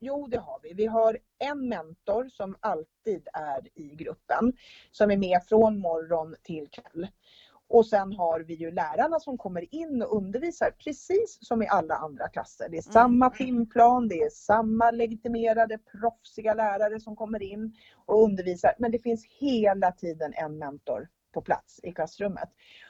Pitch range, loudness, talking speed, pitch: 180-240 Hz, -27 LUFS, 165 wpm, 220 Hz